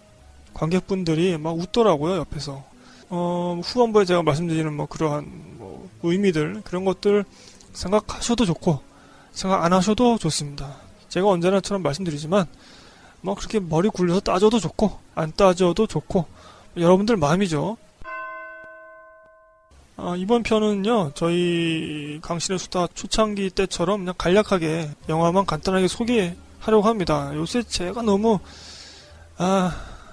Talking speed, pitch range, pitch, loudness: 285 characters per minute, 150-200 Hz, 175 Hz, -22 LUFS